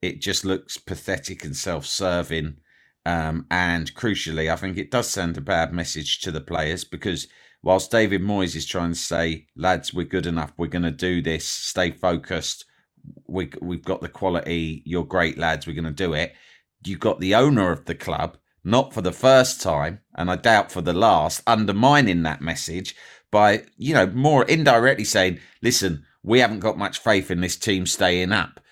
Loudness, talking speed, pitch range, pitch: -22 LUFS, 190 wpm, 80-100 Hz, 90 Hz